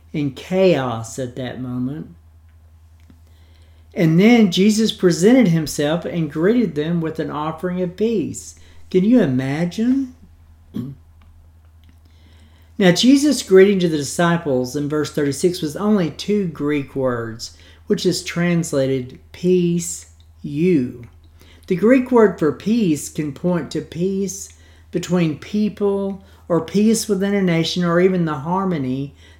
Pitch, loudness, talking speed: 155 Hz, -18 LUFS, 120 wpm